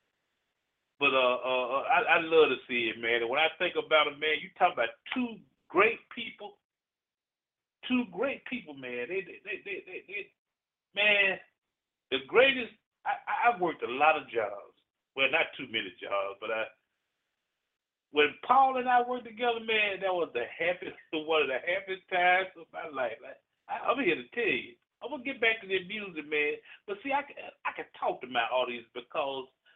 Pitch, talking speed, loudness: 190 Hz, 190 wpm, -29 LUFS